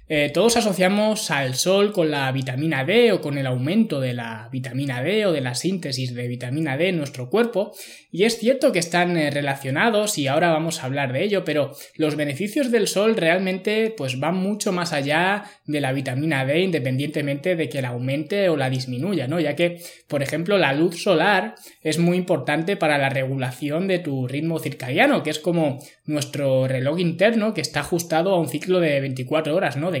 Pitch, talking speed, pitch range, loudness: 155 Hz, 195 wpm, 140-185 Hz, -22 LUFS